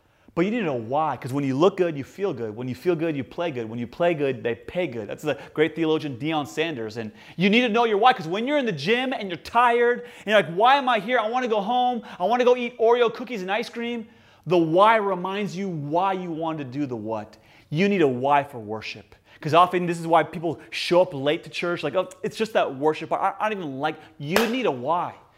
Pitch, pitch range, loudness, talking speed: 175 Hz, 145-220 Hz, -23 LUFS, 270 wpm